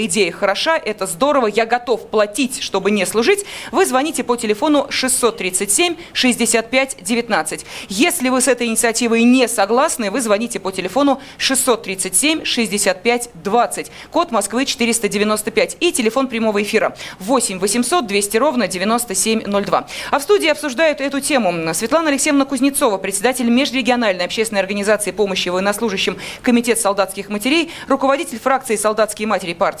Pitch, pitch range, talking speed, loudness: 235 Hz, 205-270 Hz, 130 wpm, -17 LUFS